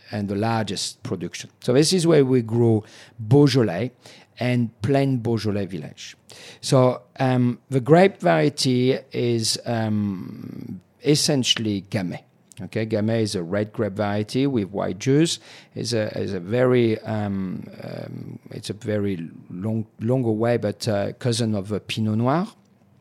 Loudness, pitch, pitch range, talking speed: -22 LUFS, 115 Hz, 105-130 Hz, 140 wpm